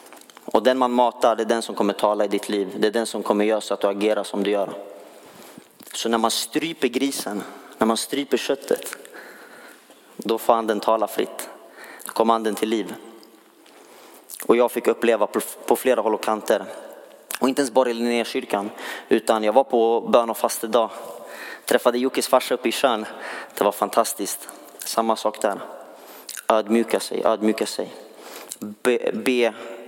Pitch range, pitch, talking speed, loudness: 105-125 Hz, 115 Hz, 175 wpm, -22 LUFS